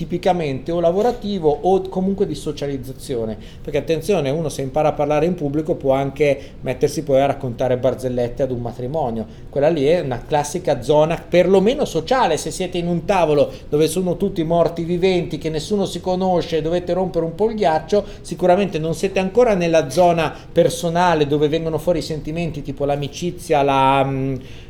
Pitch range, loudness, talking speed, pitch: 140-175 Hz, -19 LUFS, 170 wpm, 160 Hz